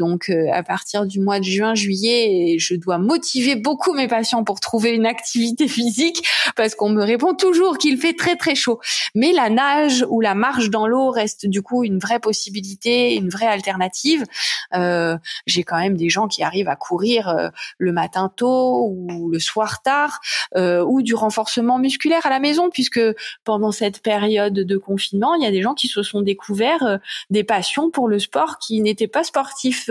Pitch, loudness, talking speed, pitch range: 220 Hz, -19 LUFS, 195 wpm, 195-255 Hz